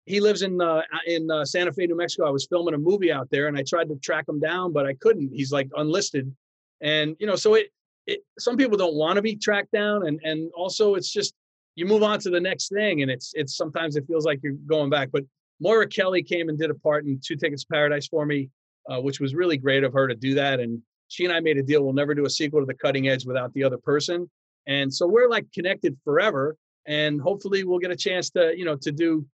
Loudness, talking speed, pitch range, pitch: -24 LUFS, 260 wpm, 145-180 Hz, 155 Hz